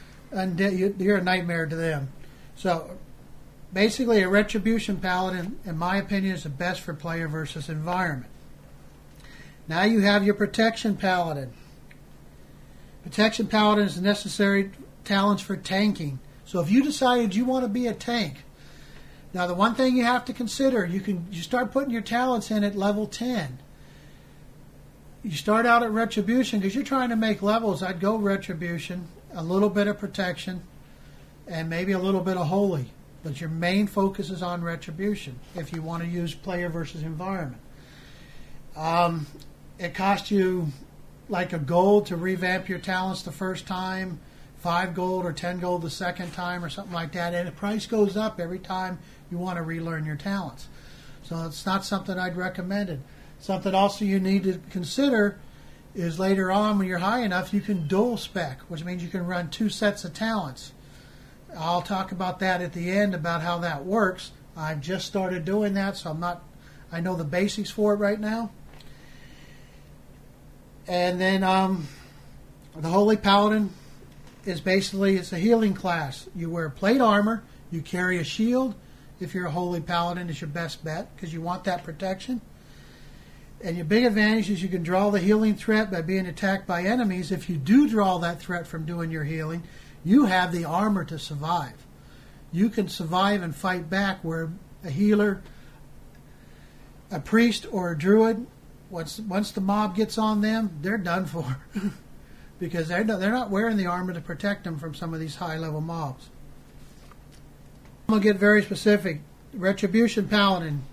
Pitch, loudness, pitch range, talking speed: 185 Hz, -26 LUFS, 165-205 Hz, 175 wpm